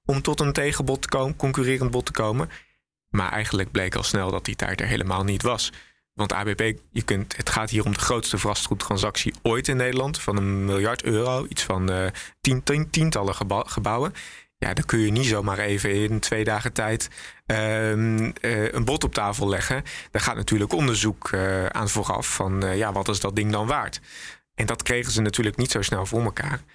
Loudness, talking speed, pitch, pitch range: -24 LUFS, 200 wpm, 110 Hz, 100-125 Hz